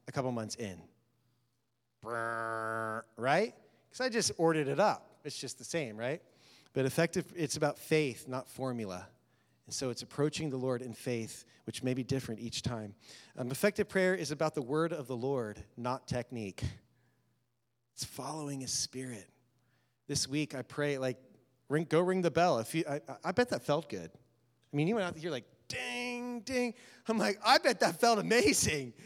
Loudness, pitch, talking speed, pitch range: -34 LUFS, 130 Hz, 175 wpm, 120-160 Hz